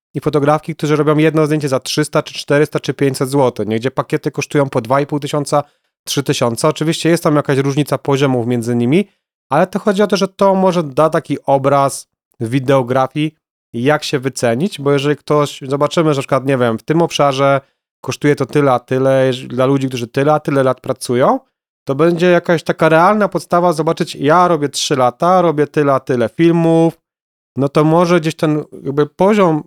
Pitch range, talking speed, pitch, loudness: 135-165 Hz, 180 wpm, 150 Hz, -14 LUFS